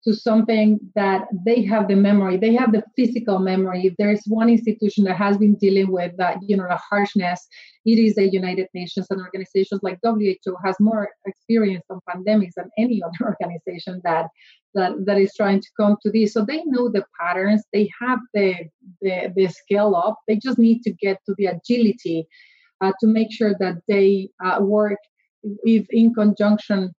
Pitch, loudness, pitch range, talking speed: 205 Hz, -20 LUFS, 190-215 Hz, 190 wpm